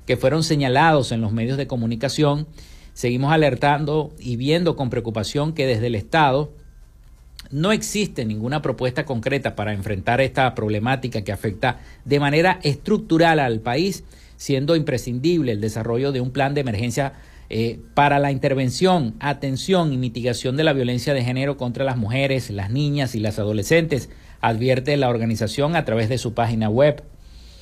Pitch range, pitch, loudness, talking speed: 115-145 Hz, 130 Hz, -21 LUFS, 155 wpm